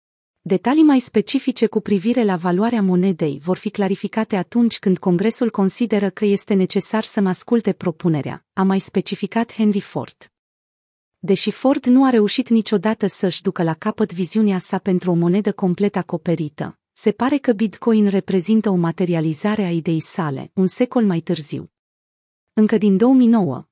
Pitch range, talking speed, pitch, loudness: 180-220 Hz, 150 wpm, 200 Hz, -19 LUFS